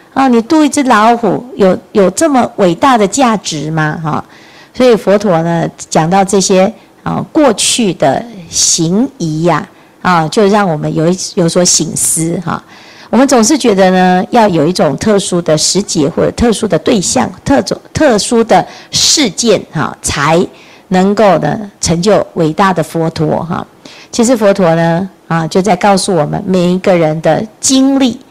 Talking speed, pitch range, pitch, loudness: 250 characters per minute, 165-225 Hz, 190 Hz, -10 LUFS